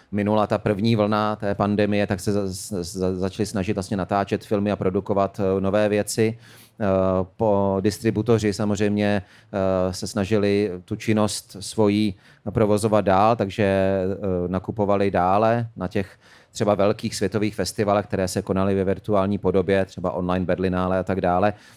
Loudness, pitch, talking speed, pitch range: -22 LUFS, 100 Hz, 130 wpm, 95-105 Hz